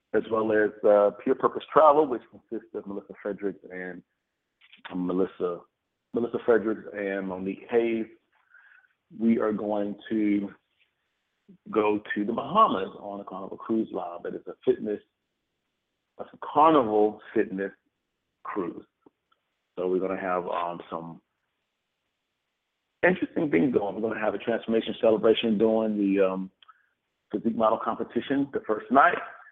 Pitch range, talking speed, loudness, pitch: 100-115 Hz, 135 wpm, -26 LUFS, 105 Hz